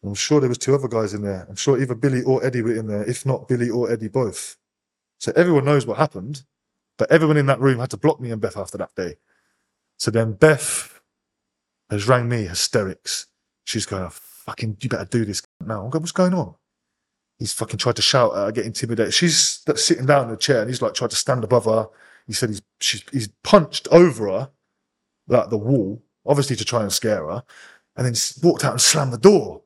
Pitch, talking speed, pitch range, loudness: 120 Hz, 225 wpm, 110-145 Hz, -20 LUFS